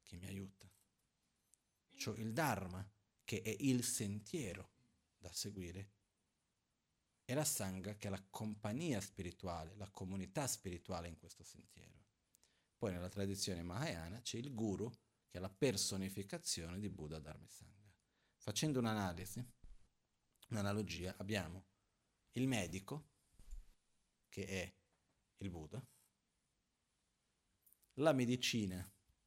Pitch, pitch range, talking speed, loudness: 100 Hz, 95-110 Hz, 110 wpm, -43 LUFS